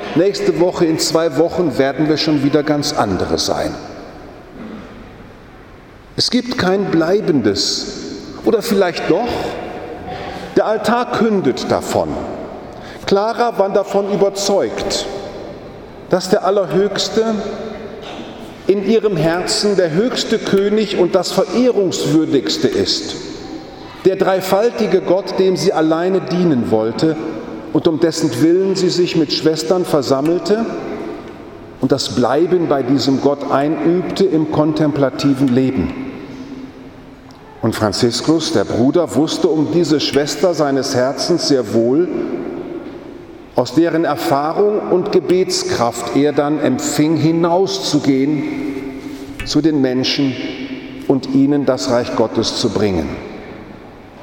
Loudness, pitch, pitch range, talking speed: -16 LUFS, 170 Hz, 145-205 Hz, 110 wpm